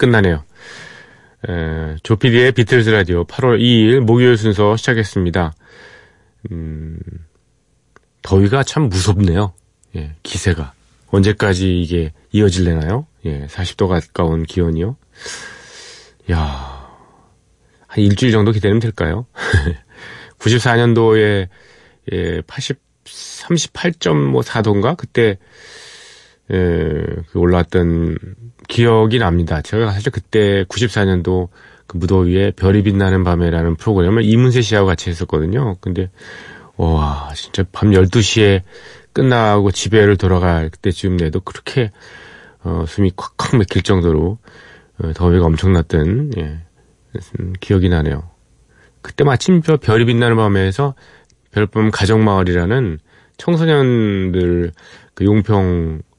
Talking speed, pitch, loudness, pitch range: 230 characters per minute, 95 Hz, -15 LUFS, 85-110 Hz